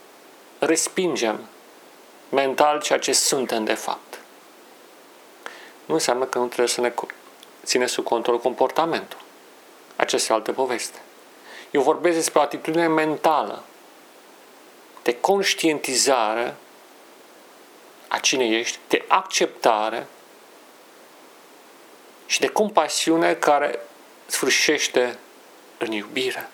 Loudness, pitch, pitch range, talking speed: -22 LUFS, 150 Hz, 120-160 Hz, 95 wpm